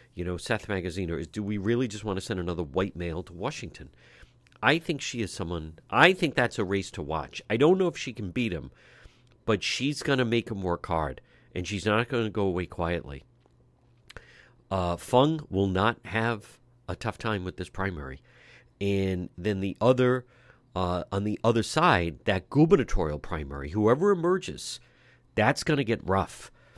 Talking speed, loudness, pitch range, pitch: 190 wpm, -28 LUFS, 90-120 Hz, 105 Hz